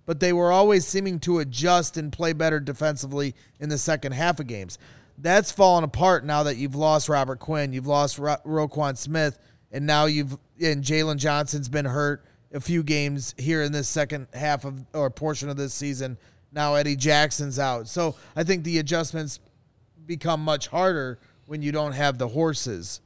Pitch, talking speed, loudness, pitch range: 150 Hz, 180 wpm, -24 LUFS, 140-160 Hz